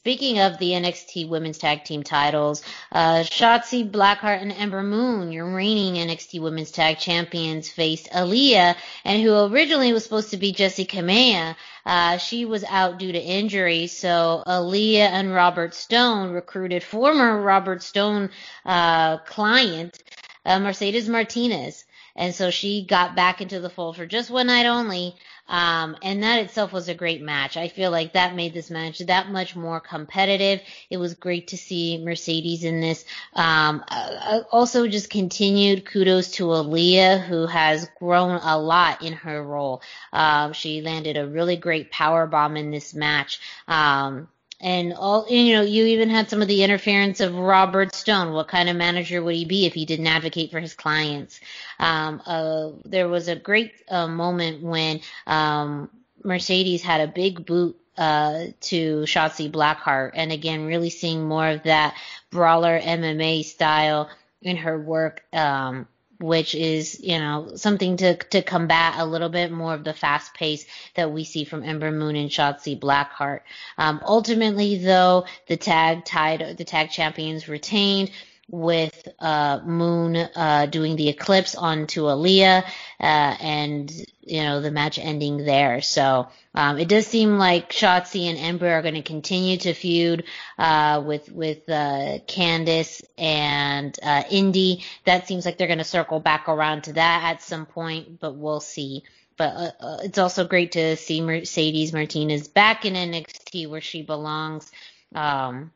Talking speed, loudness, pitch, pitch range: 165 wpm, -21 LUFS, 170 Hz, 155-190 Hz